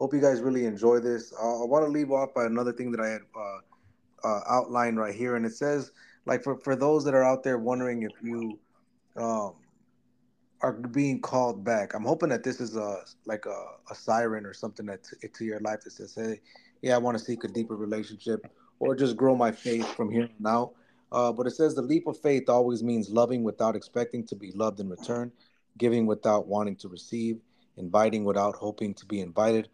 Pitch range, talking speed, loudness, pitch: 110-125 Hz, 215 wpm, -28 LUFS, 115 Hz